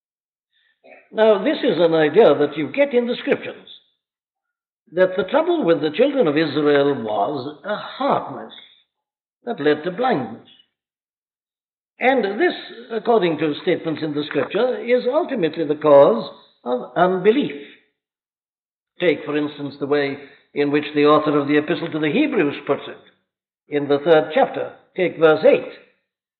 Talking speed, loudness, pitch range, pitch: 145 wpm, -19 LUFS, 150-245 Hz, 160 Hz